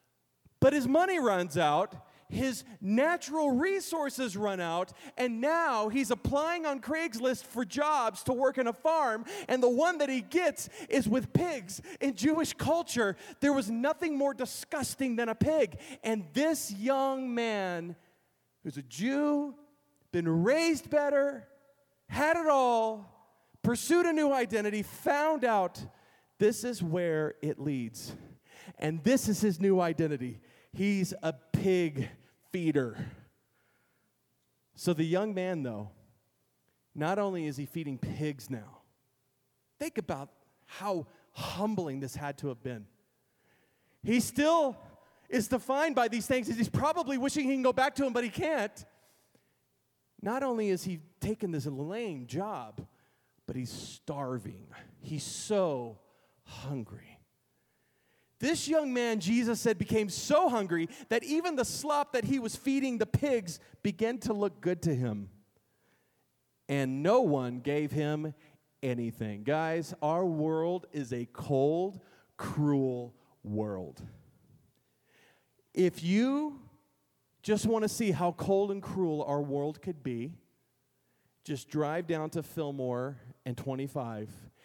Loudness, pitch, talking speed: -31 LUFS, 190 Hz, 135 wpm